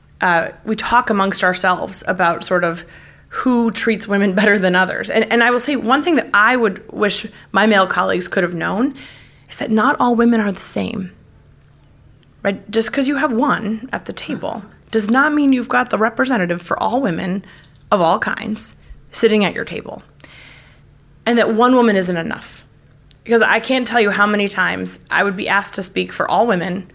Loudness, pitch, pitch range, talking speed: -16 LUFS, 205 Hz, 175-235 Hz, 195 wpm